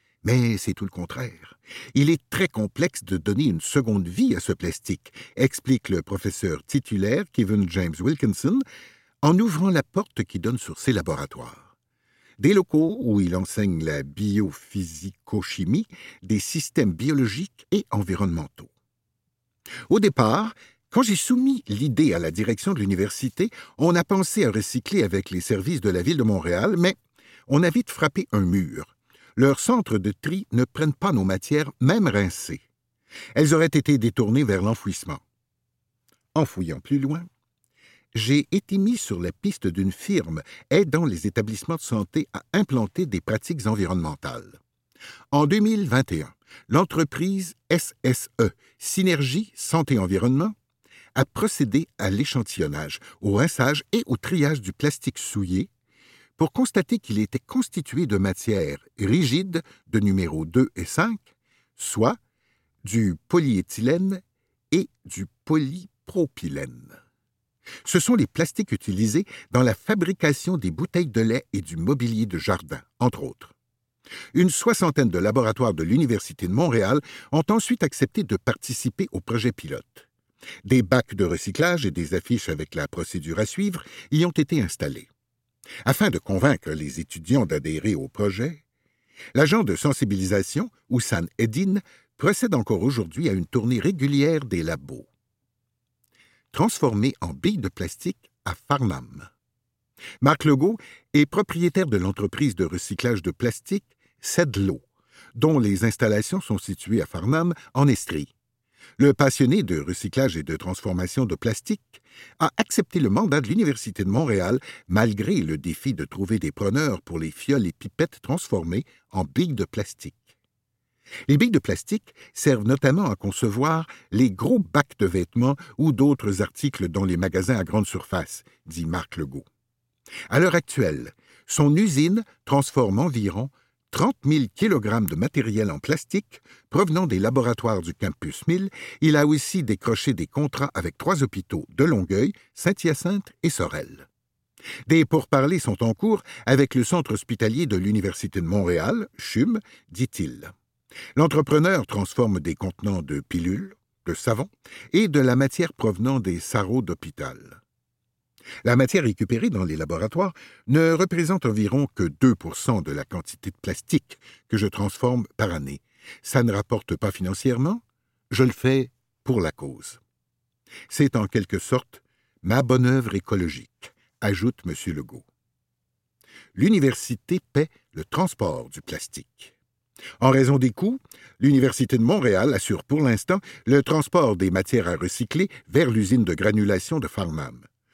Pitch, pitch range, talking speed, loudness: 125 Hz, 100-155 Hz, 145 wpm, -23 LUFS